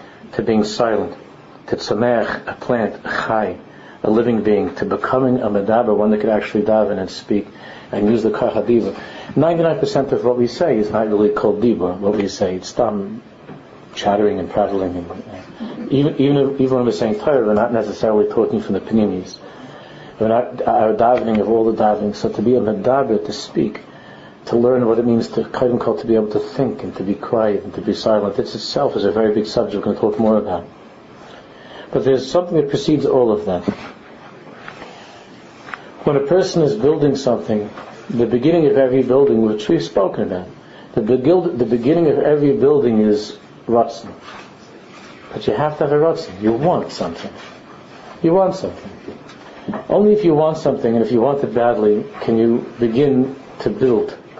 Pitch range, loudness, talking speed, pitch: 105-140 Hz, -17 LUFS, 190 wpm, 120 Hz